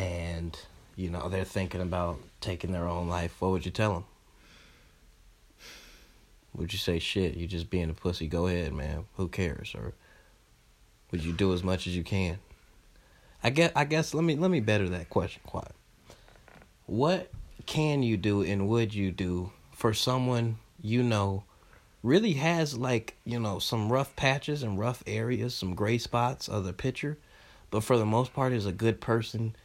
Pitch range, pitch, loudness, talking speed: 90-120 Hz, 100 Hz, -30 LUFS, 180 wpm